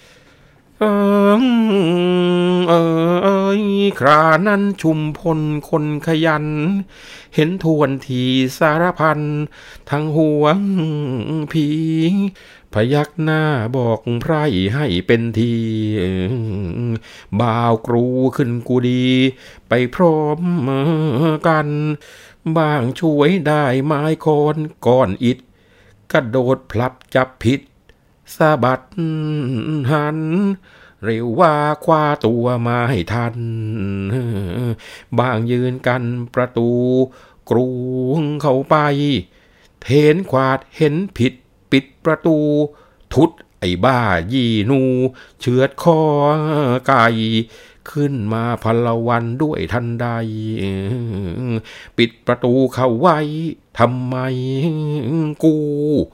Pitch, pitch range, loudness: 135 Hz, 120-155 Hz, -17 LUFS